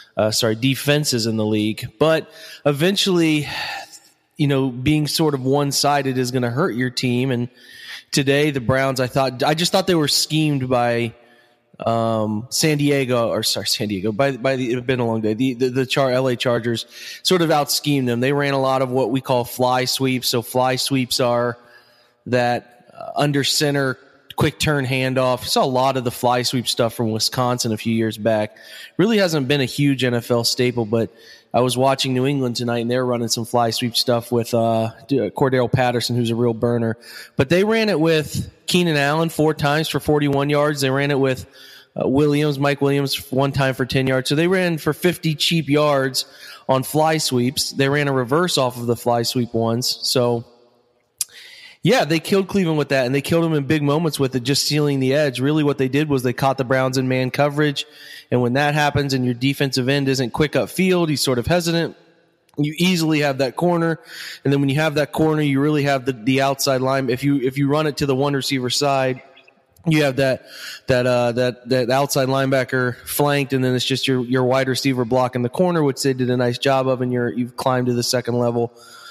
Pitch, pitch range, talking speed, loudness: 135 Hz, 125-145 Hz, 215 wpm, -19 LUFS